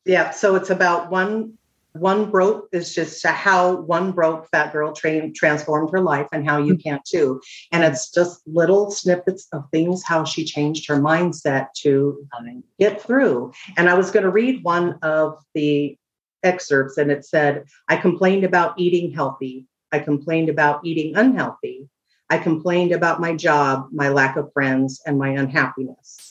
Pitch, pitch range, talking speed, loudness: 160 Hz, 145-180 Hz, 165 wpm, -19 LUFS